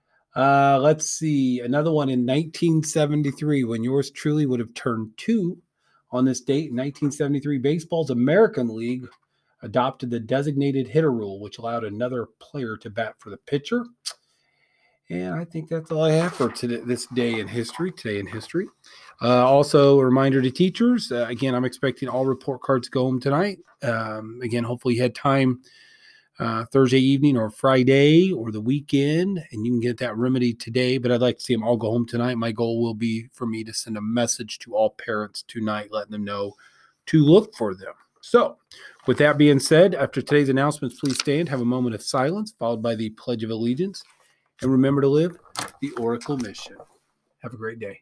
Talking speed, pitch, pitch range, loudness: 190 wpm, 130 Hz, 120-145 Hz, -22 LUFS